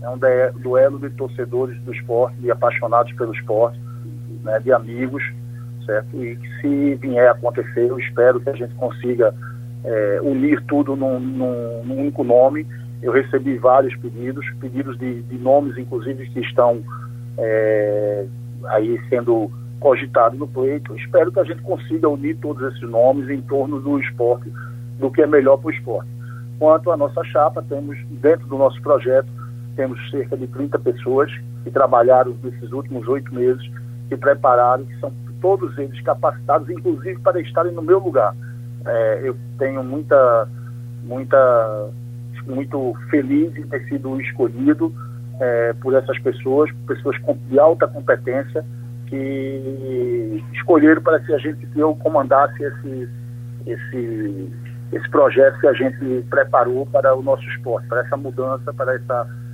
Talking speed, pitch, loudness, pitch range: 155 wpm, 125 Hz, -19 LUFS, 120-135 Hz